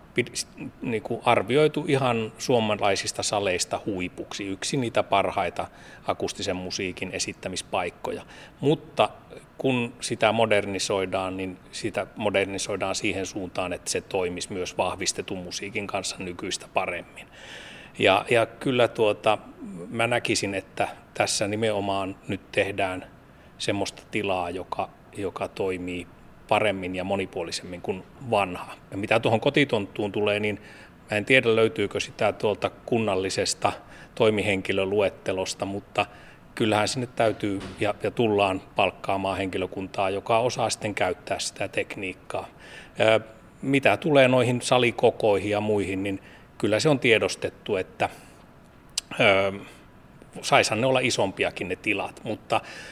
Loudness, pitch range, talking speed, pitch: -26 LUFS, 95-115 Hz, 110 wpm, 105 Hz